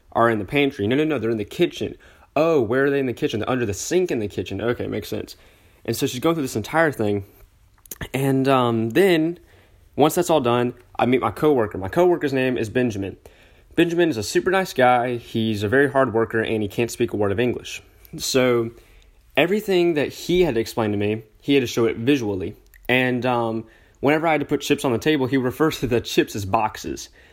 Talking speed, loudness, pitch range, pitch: 230 wpm, -21 LUFS, 110-145 Hz, 125 Hz